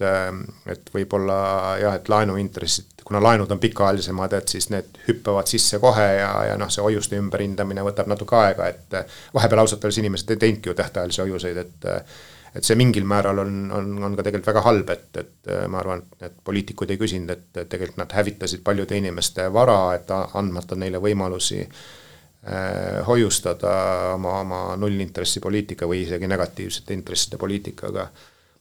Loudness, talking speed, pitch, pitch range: -22 LUFS, 155 wpm, 100 Hz, 95-105 Hz